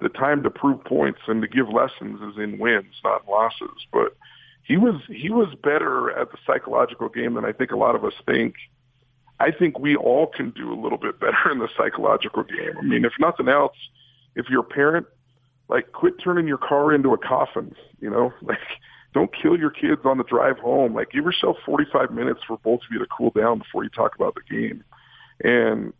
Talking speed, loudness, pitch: 215 wpm, -22 LUFS, 145 Hz